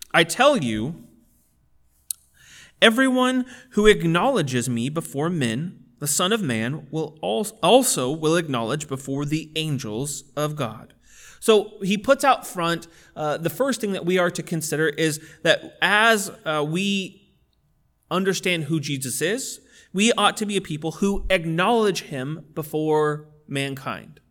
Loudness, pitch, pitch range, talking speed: -22 LUFS, 165 Hz, 150-200 Hz, 140 wpm